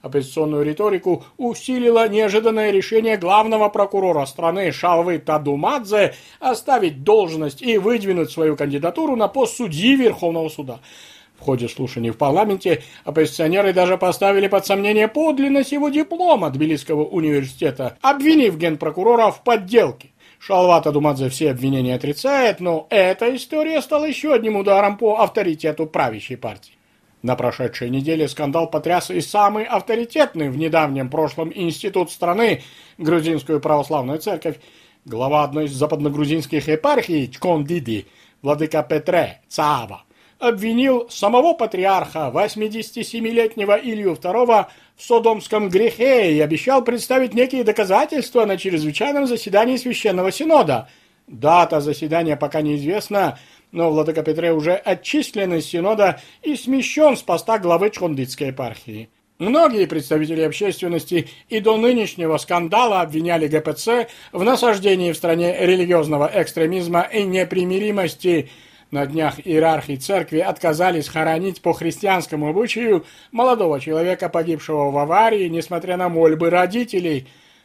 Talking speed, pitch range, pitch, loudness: 120 wpm, 155-220 Hz, 180 Hz, -18 LUFS